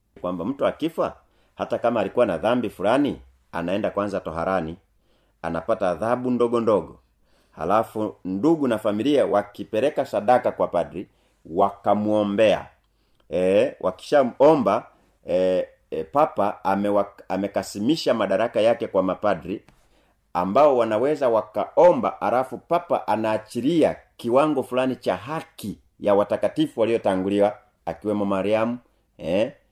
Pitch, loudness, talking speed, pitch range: 105 Hz, -23 LUFS, 100 wpm, 95-120 Hz